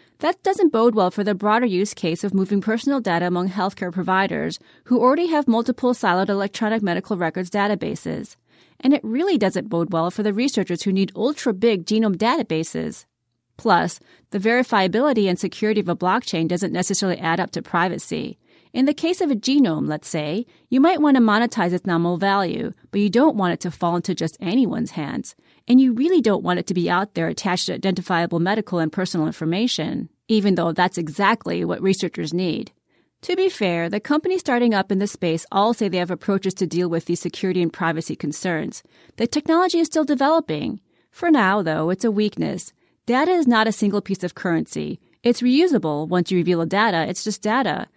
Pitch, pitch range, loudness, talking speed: 200 Hz, 180-240 Hz, -21 LUFS, 195 wpm